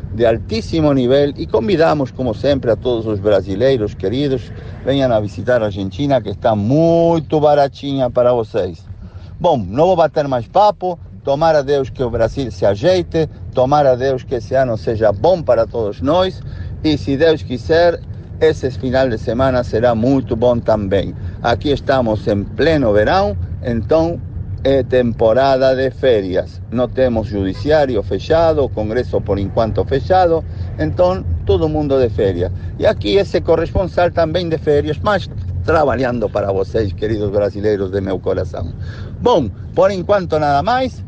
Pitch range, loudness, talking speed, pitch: 100-145 Hz, -16 LUFS, 155 wpm, 125 Hz